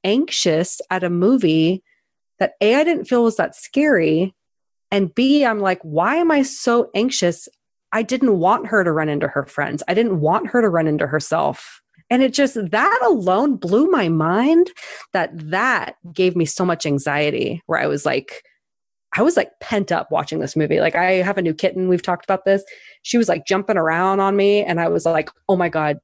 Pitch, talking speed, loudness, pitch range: 190 Hz, 205 wpm, -18 LUFS, 165-235 Hz